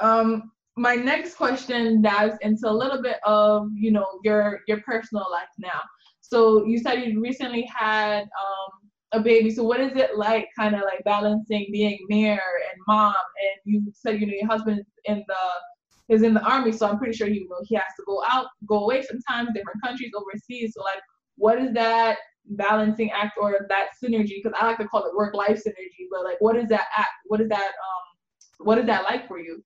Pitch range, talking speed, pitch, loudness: 205-230 Hz, 205 wpm, 215 Hz, -23 LUFS